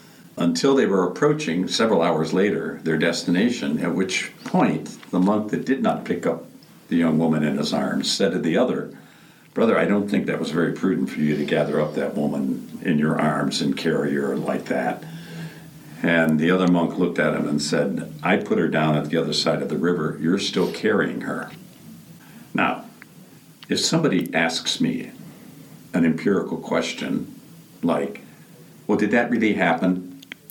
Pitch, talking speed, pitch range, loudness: 90 Hz, 175 wpm, 80-105 Hz, -22 LUFS